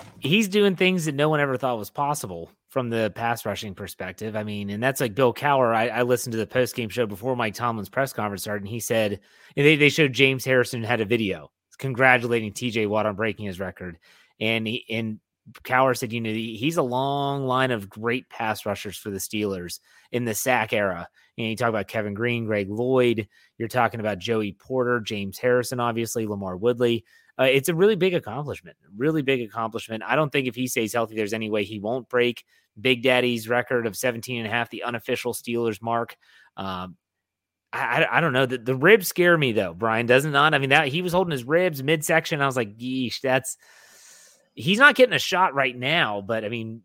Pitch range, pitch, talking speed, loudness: 110-130 Hz, 120 Hz, 215 wpm, -23 LUFS